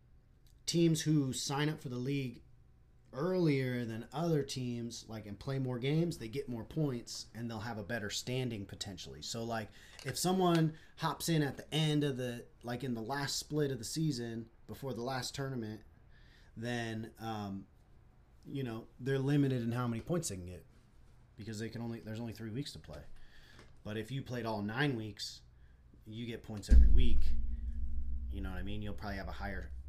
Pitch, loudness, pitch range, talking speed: 115 Hz, -37 LUFS, 105-135 Hz, 190 wpm